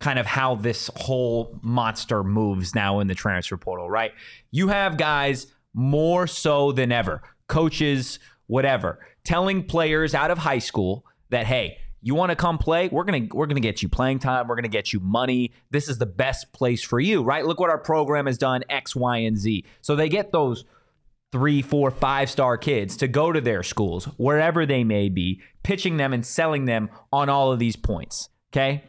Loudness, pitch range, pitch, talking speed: -23 LUFS, 115-150 Hz, 135 Hz, 195 wpm